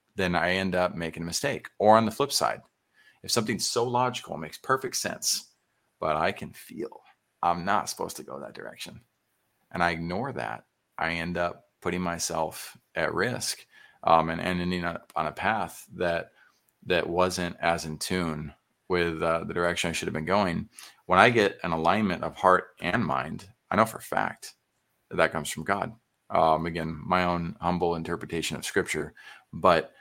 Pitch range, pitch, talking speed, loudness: 85-90 Hz, 85 Hz, 185 wpm, -27 LUFS